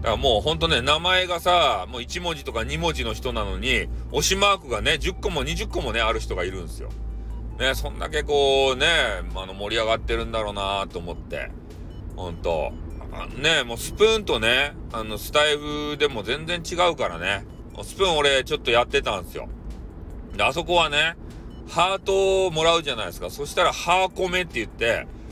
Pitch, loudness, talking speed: 150 Hz, -23 LUFS, 365 characters per minute